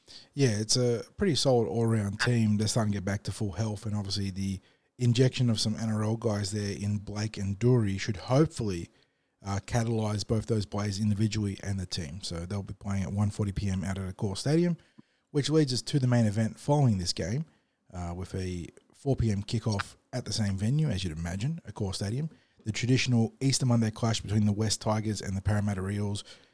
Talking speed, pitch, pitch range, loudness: 200 wpm, 110 Hz, 100-120 Hz, -30 LUFS